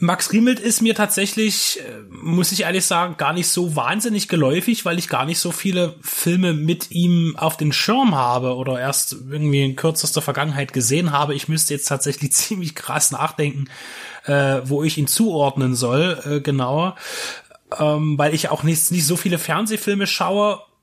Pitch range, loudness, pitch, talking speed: 145-180 Hz, -19 LUFS, 160 Hz, 175 wpm